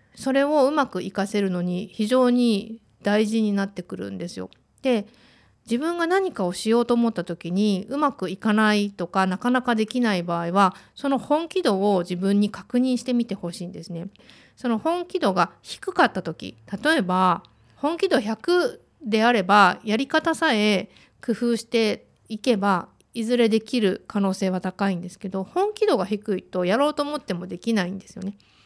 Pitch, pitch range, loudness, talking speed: 215 Hz, 190-250 Hz, -23 LUFS, 335 characters per minute